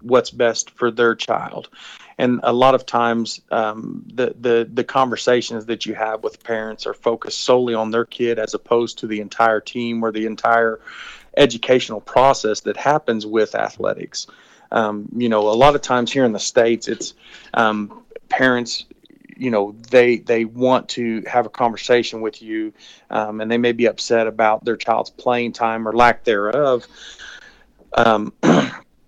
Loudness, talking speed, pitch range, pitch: -19 LUFS, 165 wpm, 110-120 Hz, 115 Hz